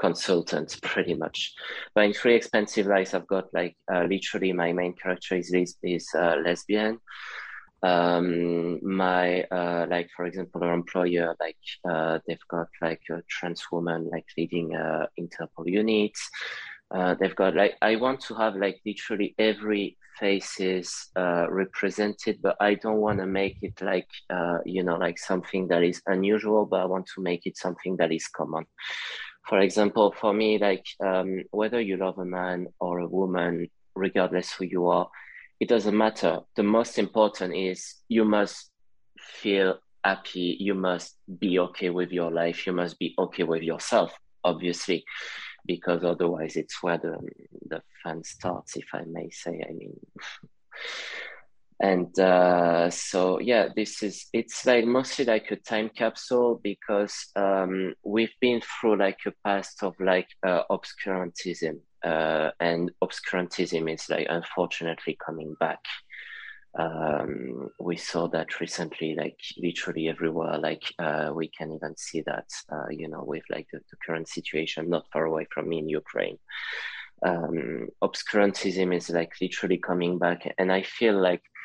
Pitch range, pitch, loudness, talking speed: 85-100 Hz, 90 Hz, -27 LUFS, 155 wpm